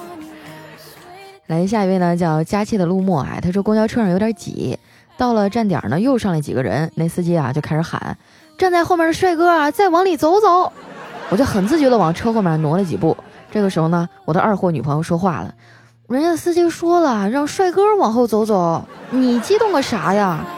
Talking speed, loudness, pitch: 295 characters per minute, -17 LUFS, 205 Hz